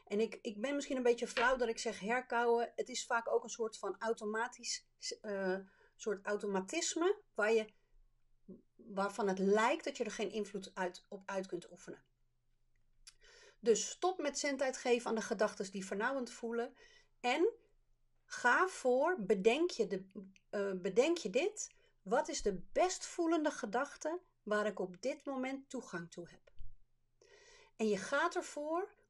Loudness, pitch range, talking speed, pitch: -37 LUFS, 200-310 Hz, 160 wpm, 235 Hz